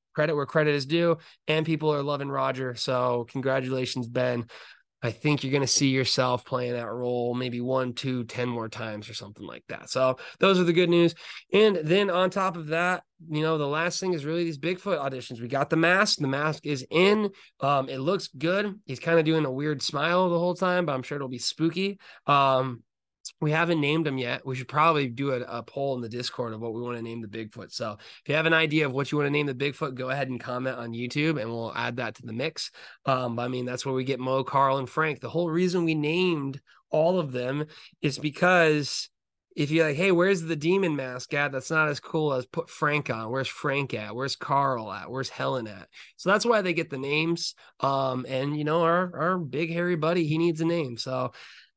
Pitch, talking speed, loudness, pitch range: 145 Hz, 235 wpm, -26 LUFS, 130-165 Hz